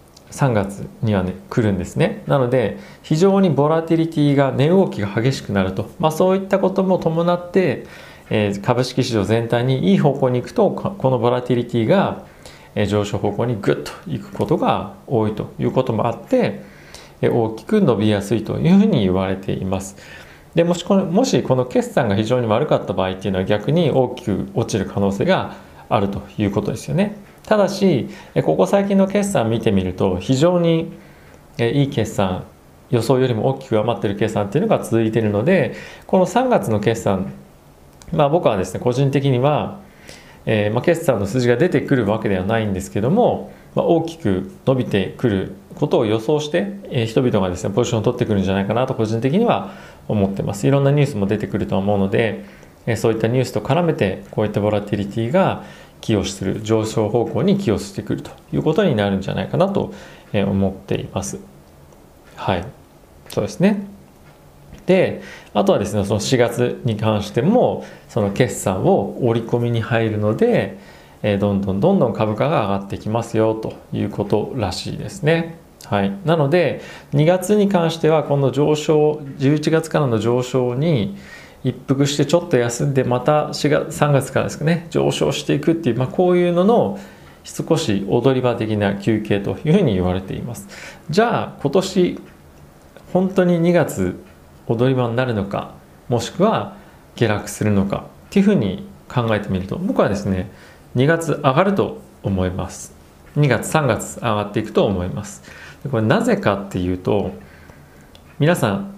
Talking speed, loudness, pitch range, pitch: 320 characters per minute, -19 LUFS, 100-150 Hz, 120 Hz